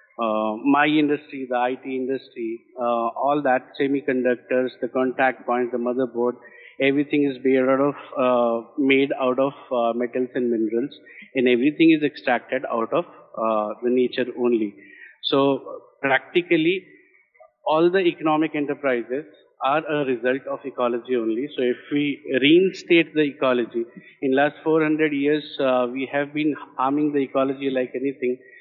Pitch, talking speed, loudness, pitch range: 135 Hz, 145 wpm, -22 LUFS, 125-145 Hz